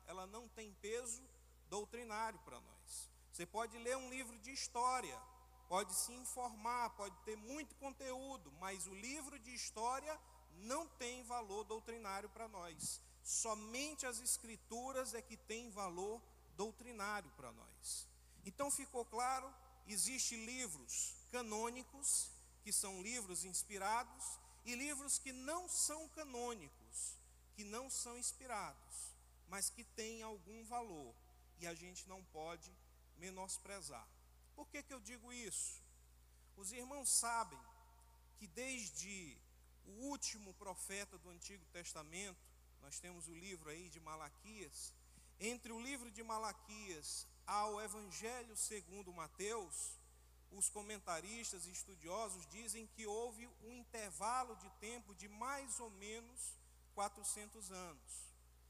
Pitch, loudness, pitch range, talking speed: 215 Hz, -46 LUFS, 175-240 Hz, 125 wpm